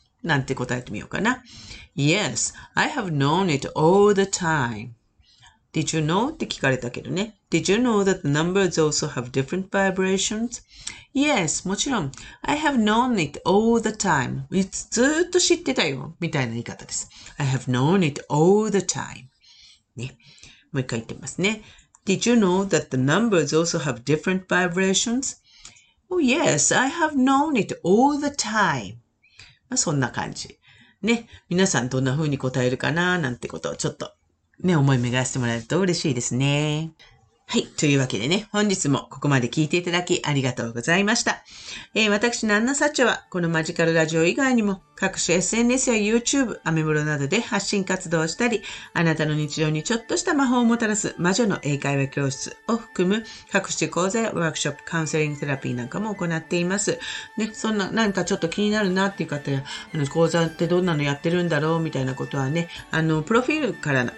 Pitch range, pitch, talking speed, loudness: 140-210 Hz, 170 Hz, 495 characters per minute, -22 LUFS